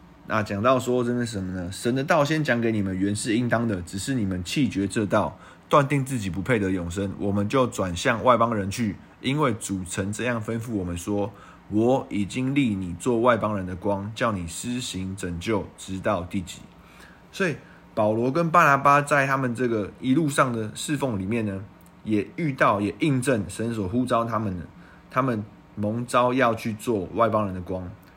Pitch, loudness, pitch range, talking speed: 110 Hz, -25 LUFS, 95-125 Hz, 270 characters per minute